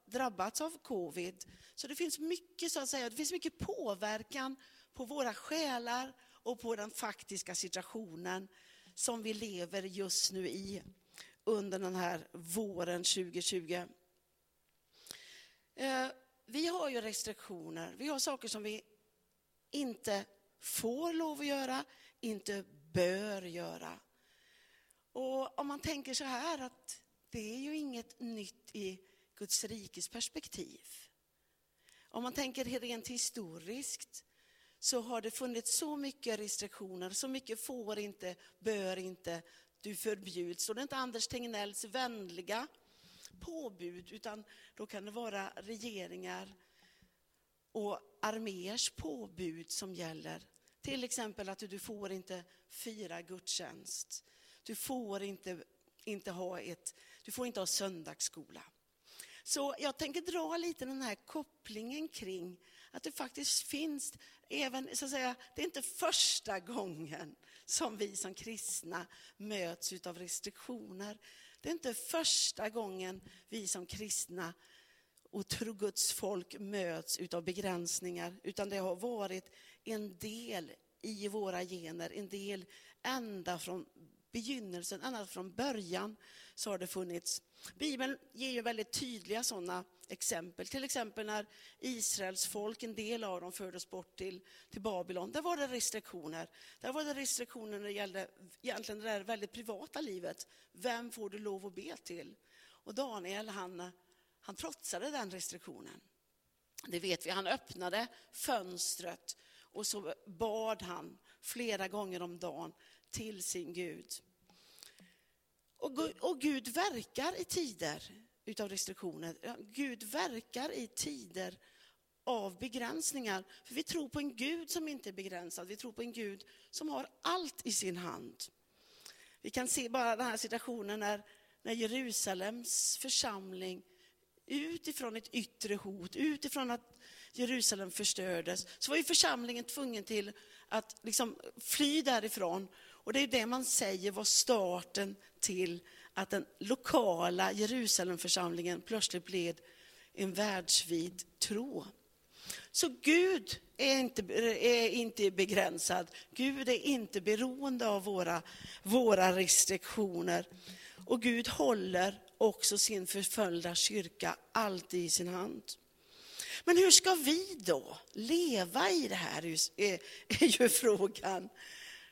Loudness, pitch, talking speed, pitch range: -37 LUFS, 215 Hz, 130 wpm, 185-255 Hz